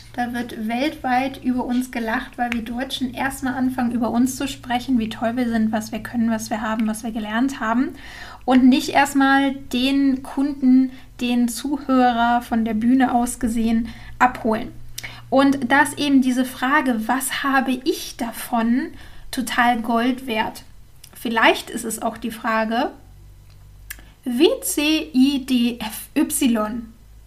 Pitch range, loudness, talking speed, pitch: 230-265 Hz, -20 LUFS, 135 wpm, 245 Hz